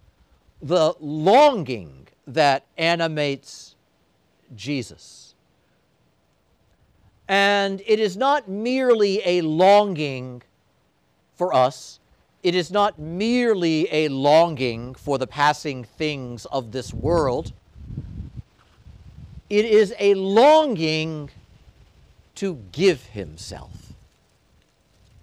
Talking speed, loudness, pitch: 80 wpm, -20 LUFS, 145 Hz